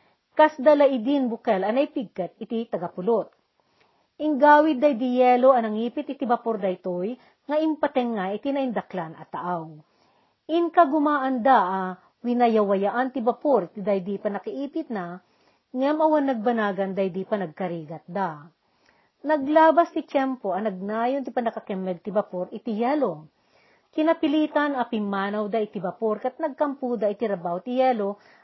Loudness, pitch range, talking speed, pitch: -24 LUFS, 200-280 Hz, 135 wpm, 235 Hz